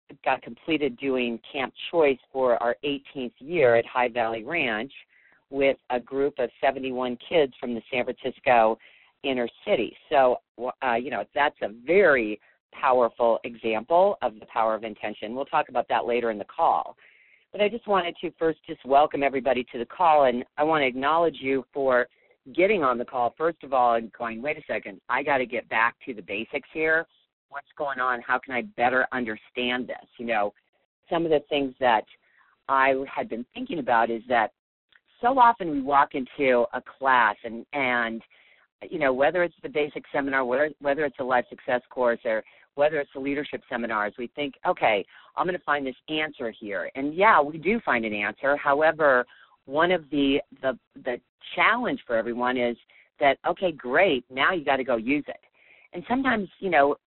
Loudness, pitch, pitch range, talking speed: -25 LUFS, 135 Hz, 120-150 Hz, 190 wpm